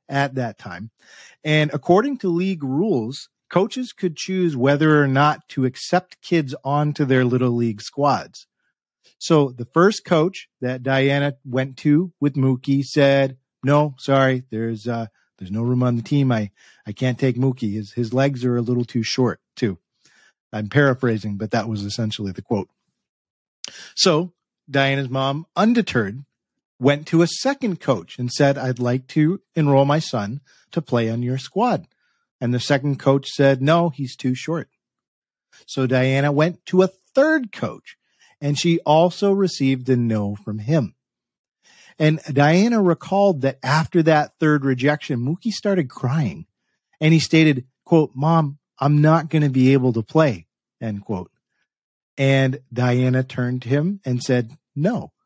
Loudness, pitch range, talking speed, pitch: -20 LUFS, 125-155 Hz, 155 wpm, 140 Hz